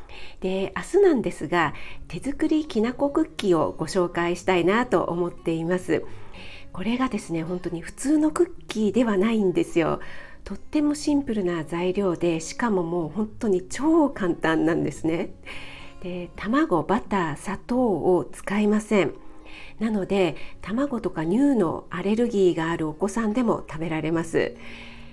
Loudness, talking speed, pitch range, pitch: -24 LUFS, 310 characters per minute, 170-235 Hz, 185 Hz